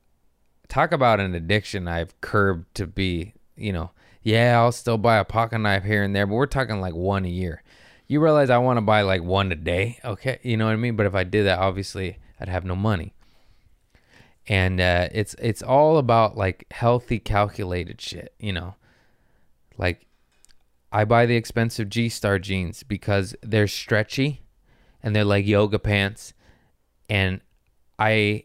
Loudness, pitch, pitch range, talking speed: -22 LUFS, 100 Hz, 95-115 Hz, 175 wpm